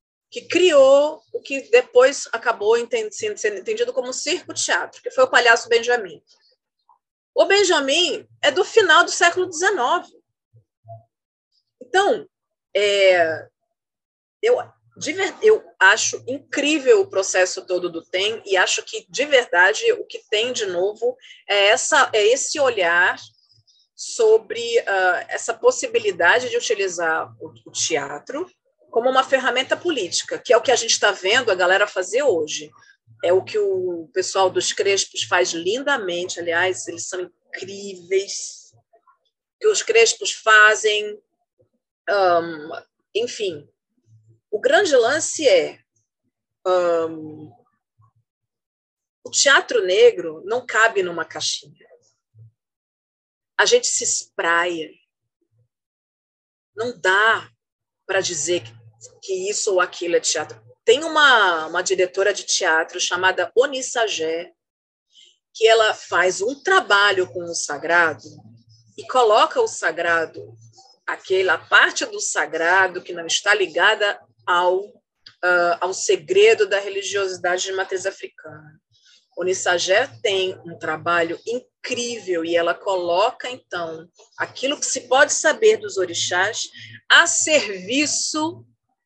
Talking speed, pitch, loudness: 120 wpm, 220 Hz, -19 LUFS